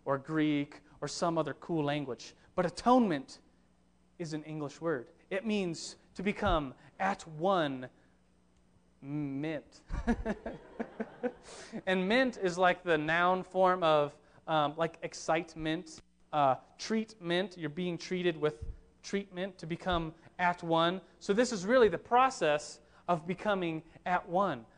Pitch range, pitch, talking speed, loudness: 150-185 Hz, 165 Hz, 125 wpm, -33 LUFS